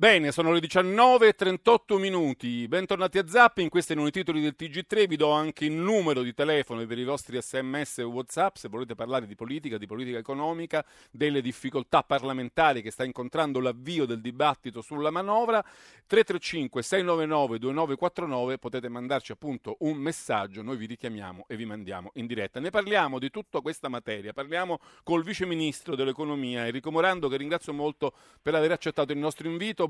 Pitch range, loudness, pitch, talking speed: 125-170 Hz, -27 LUFS, 150 Hz, 165 wpm